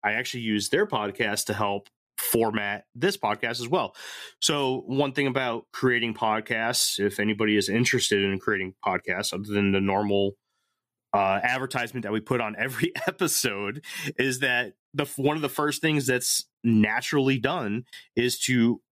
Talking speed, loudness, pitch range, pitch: 160 wpm, -26 LUFS, 105-135 Hz, 120 Hz